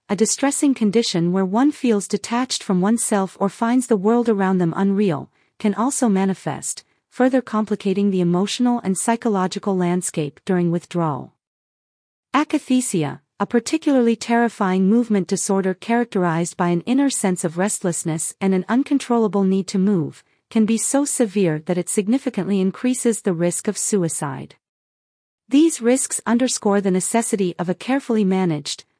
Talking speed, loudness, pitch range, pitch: 140 wpm, -20 LUFS, 185-235 Hz, 205 Hz